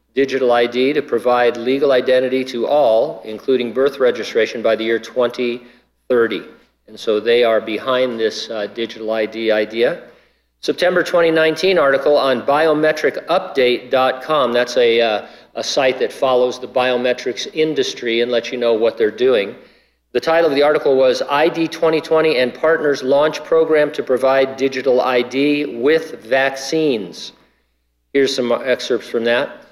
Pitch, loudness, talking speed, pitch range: 130 Hz, -16 LUFS, 140 wpm, 120-155 Hz